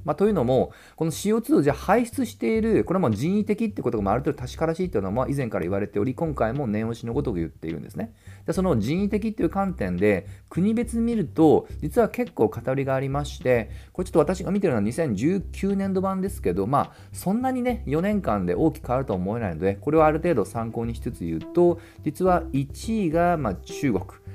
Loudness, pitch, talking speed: -24 LUFS, 155 Hz, 420 characters per minute